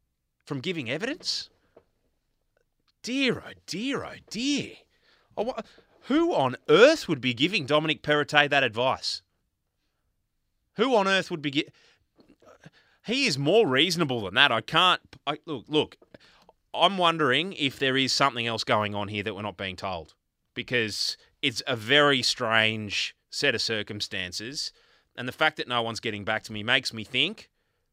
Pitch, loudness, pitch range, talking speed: 125 Hz, -25 LUFS, 105-155 Hz, 155 wpm